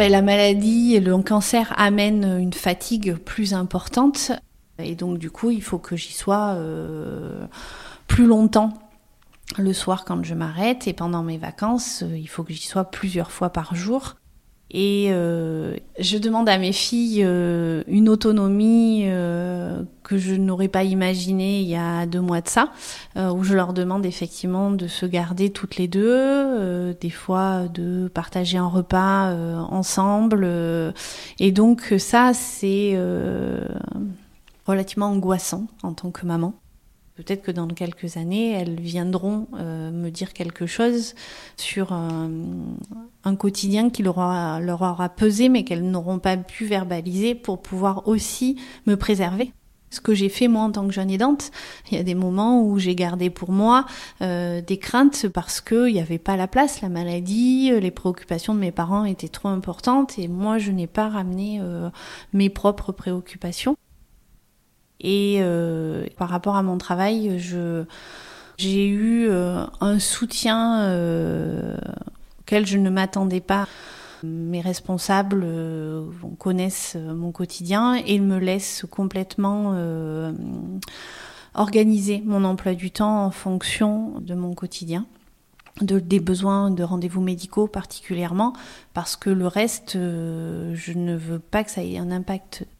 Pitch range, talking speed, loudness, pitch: 175-210 Hz, 155 wpm, -22 LUFS, 190 Hz